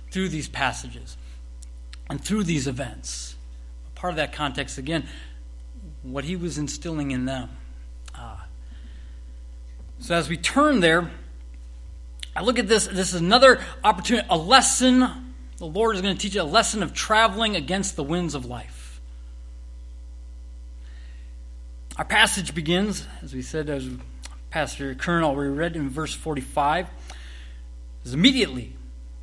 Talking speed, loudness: 140 wpm, -22 LUFS